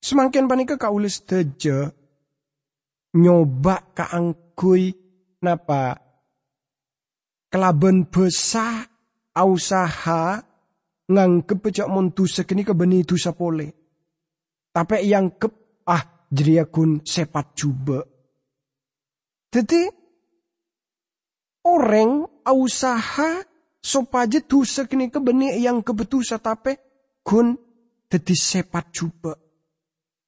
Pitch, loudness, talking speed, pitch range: 185 Hz, -20 LUFS, 85 wpm, 165-240 Hz